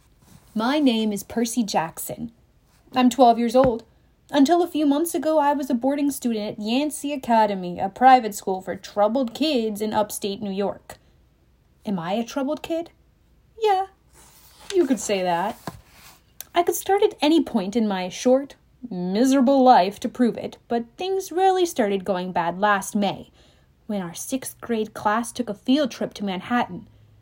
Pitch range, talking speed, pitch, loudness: 205-285 Hz, 165 wpm, 235 Hz, -22 LUFS